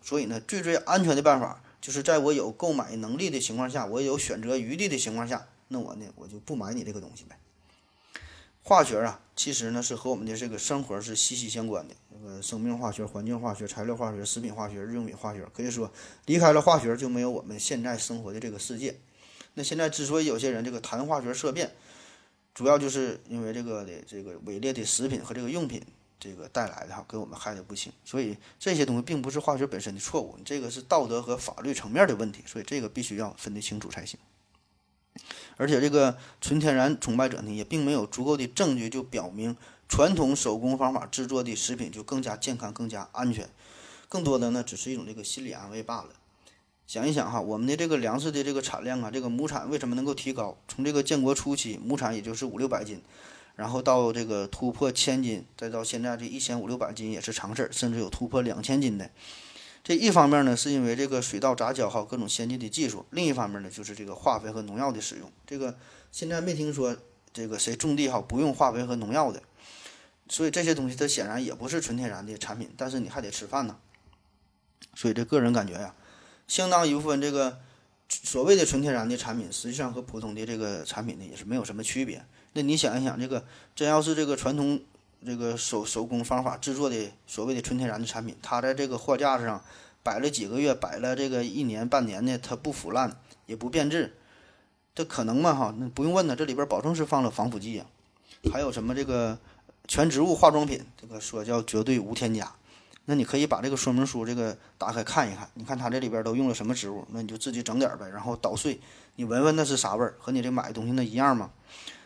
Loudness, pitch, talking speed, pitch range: -28 LUFS, 120 Hz, 345 characters per minute, 110-135 Hz